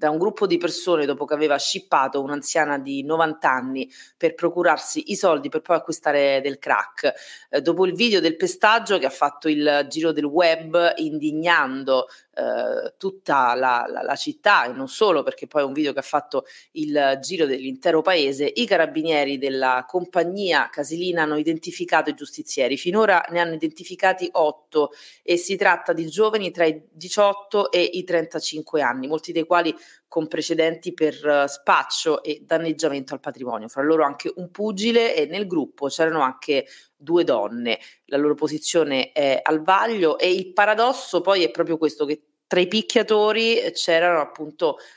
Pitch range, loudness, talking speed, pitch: 145-185 Hz, -21 LUFS, 170 wpm, 160 Hz